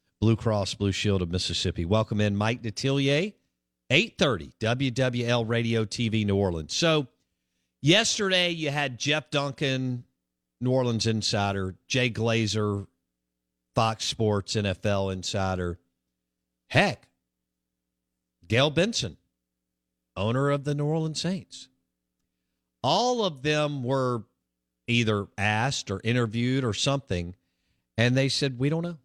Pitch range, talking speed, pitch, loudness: 85-135 Hz, 110 wpm, 110 Hz, -26 LUFS